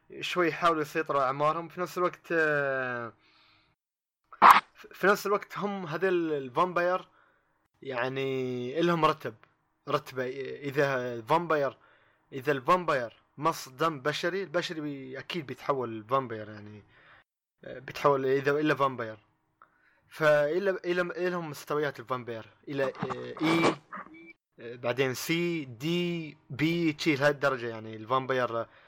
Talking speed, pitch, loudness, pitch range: 100 wpm, 145 Hz, -29 LUFS, 130-170 Hz